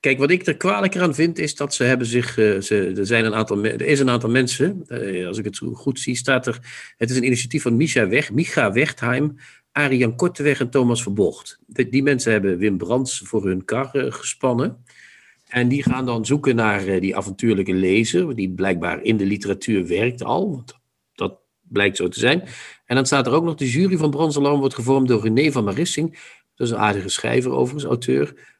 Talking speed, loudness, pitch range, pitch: 215 wpm, -20 LUFS, 105-145 Hz, 125 Hz